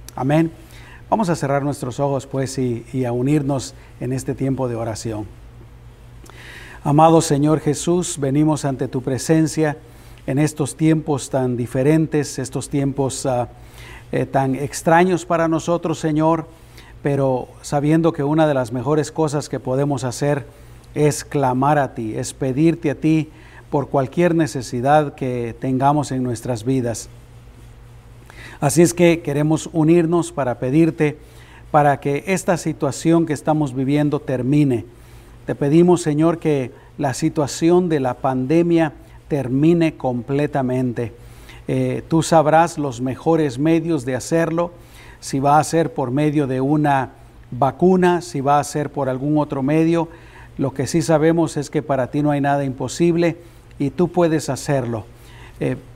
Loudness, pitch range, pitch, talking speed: -19 LUFS, 125-155 Hz, 140 Hz, 140 wpm